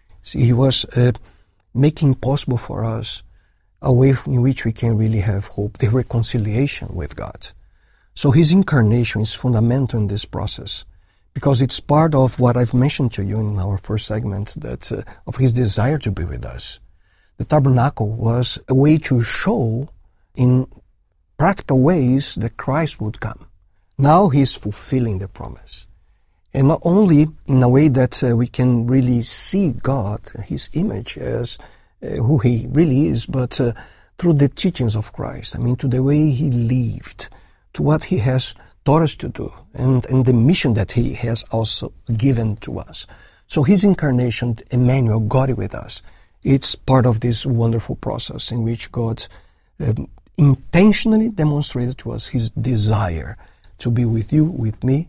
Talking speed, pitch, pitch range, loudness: 170 wpm, 120 Hz, 110-135 Hz, -18 LUFS